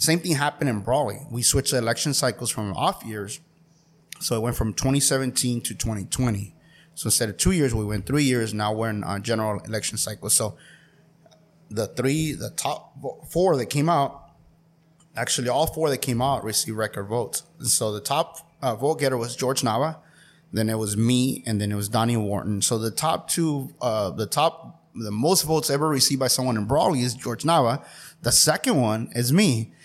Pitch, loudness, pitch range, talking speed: 125 Hz, -23 LUFS, 110-155 Hz, 195 wpm